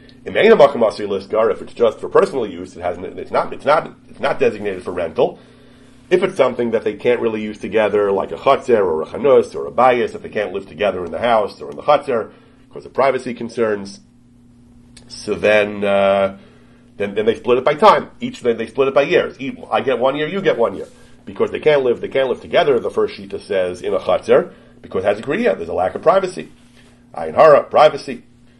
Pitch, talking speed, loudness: 125 Hz, 220 wpm, -17 LUFS